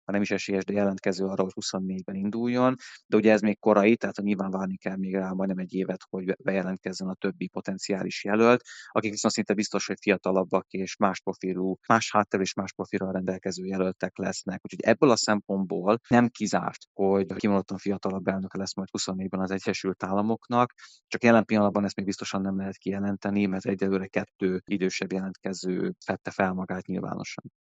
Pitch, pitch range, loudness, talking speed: 95 Hz, 95-105 Hz, -27 LUFS, 175 wpm